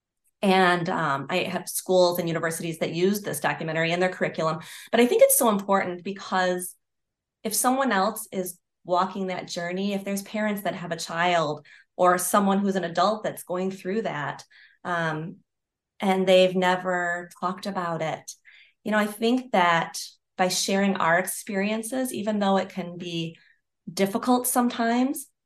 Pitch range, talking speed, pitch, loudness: 175-205 Hz, 160 wpm, 185 Hz, -25 LUFS